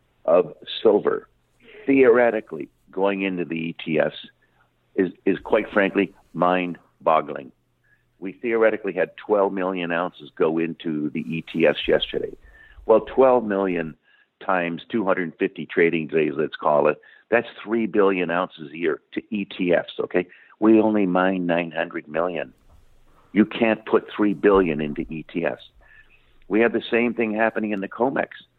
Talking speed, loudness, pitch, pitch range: 135 wpm, -22 LUFS, 95 Hz, 85-110 Hz